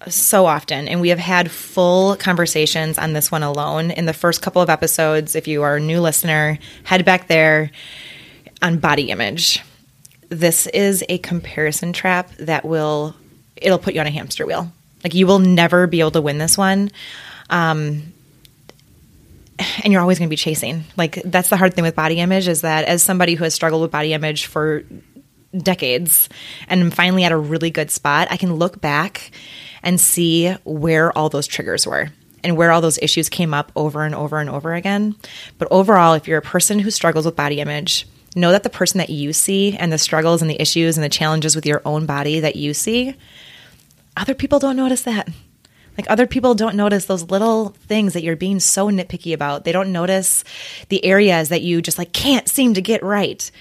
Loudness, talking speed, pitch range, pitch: -16 LUFS, 200 wpm, 155-185 Hz, 170 Hz